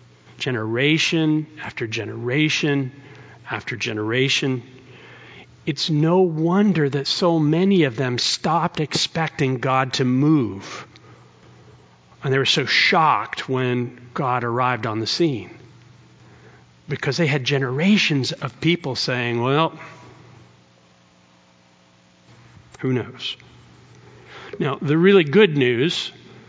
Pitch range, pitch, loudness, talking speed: 110-155 Hz, 130 Hz, -20 LUFS, 100 wpm